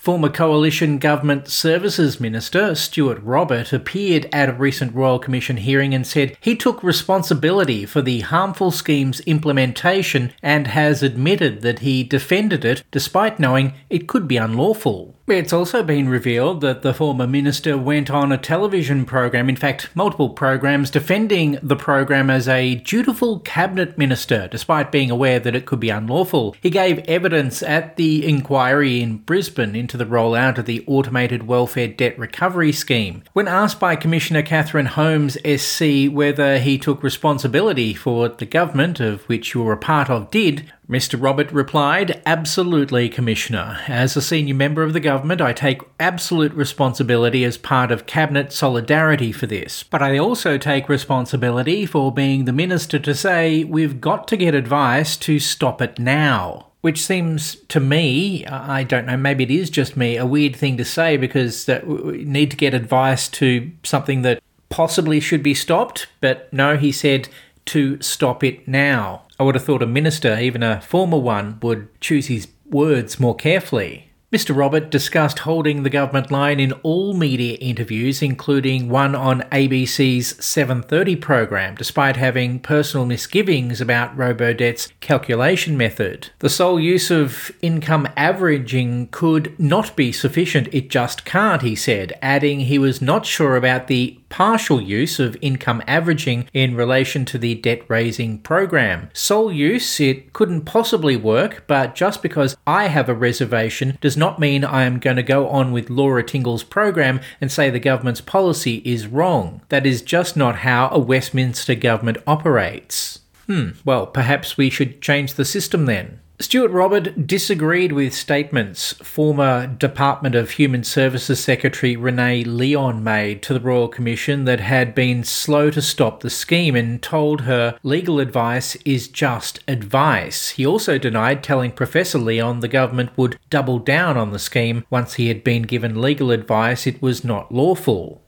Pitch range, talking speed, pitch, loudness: 125-155 Hz, 165 wpm, 140 Hz, -18 LUFS